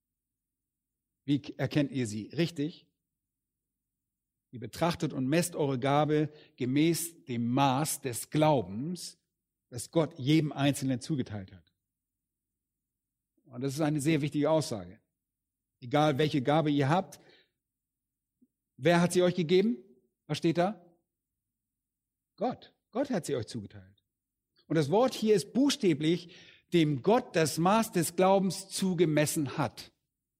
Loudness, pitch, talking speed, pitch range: -29 LUFS, 150 Hz, 120 wpm, 130-170 Hz